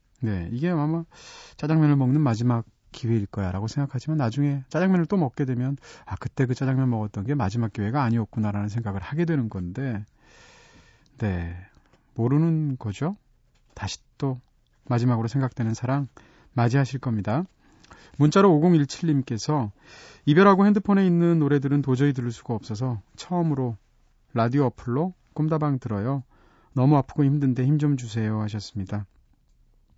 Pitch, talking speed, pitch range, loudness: 130 Hz, 325 characters per minute, 110-150 Hz, -24 LUFS